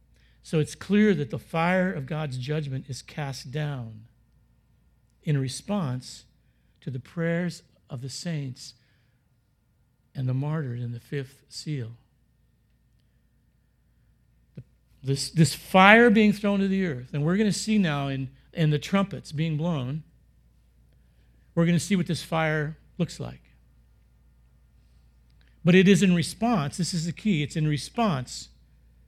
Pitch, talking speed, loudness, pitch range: 145 Hz, 140 wpm, -25 LUFS, 120-170 Hz